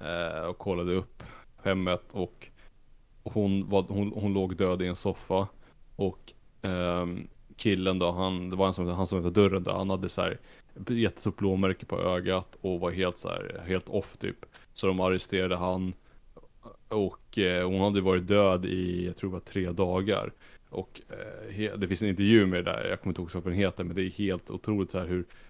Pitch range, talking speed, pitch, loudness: 90-100 Hz, 195 wpm, 95 Hz, -30 LUFS